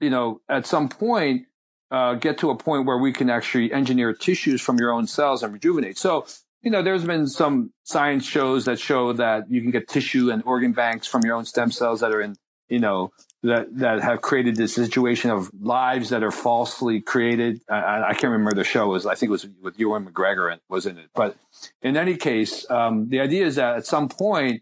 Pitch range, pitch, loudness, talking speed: 115-135 Hz, 125 Hz, -22 LUFS, 225 wpm